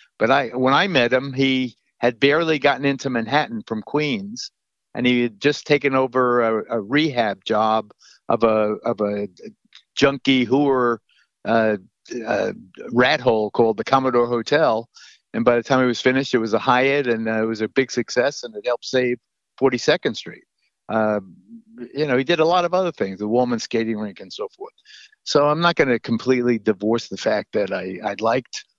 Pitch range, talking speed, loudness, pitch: 115-145 Hz, 190 wpm, -20 LUFS, 125 Hz